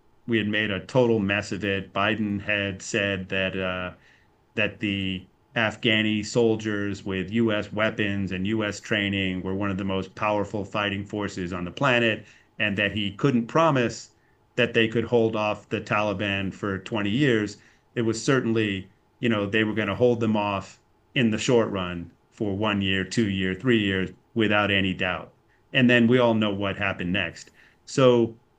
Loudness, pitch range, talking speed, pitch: -25 LUFS, 95-115 Hz, 175 wpm, 105 Hz